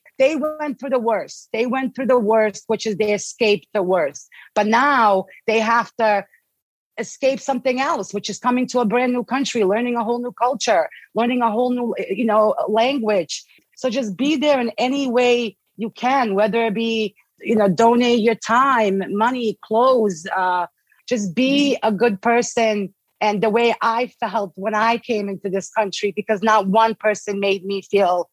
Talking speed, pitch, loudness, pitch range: 185 wpm, 225 Hz, -19 LUFS, 210-245 Hz